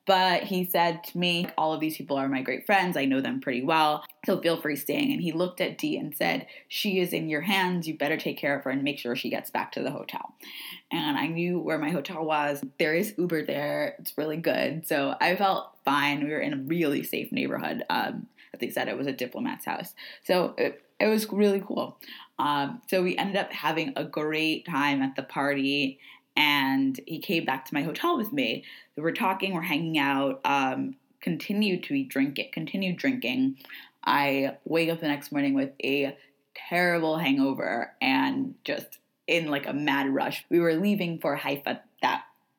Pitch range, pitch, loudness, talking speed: 140-195 Hz, 160 Hz, -27 LUFS, 205 wpm